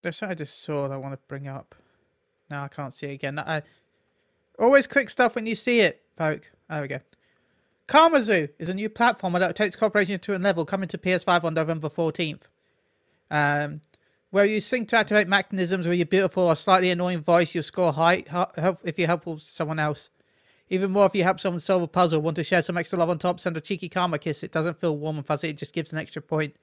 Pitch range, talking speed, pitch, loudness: 155-190 Hz, 230 wpm, 175 Hz, -24 LUFS